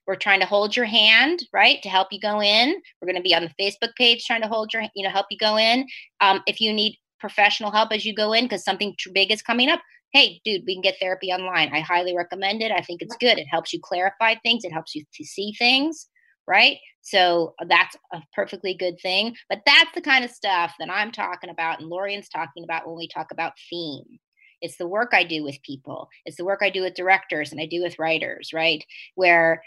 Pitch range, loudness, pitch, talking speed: 170-220 Hz, -20 LUFS, 195 Hz, 245 wpm